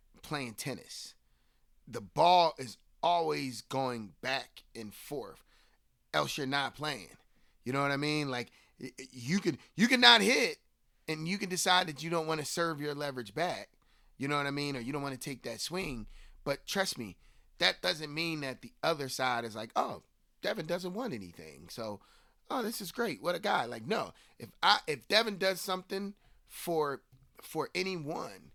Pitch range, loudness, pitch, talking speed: 130-180 Hz, -32 LUFS, 150 Hz, 185 wpm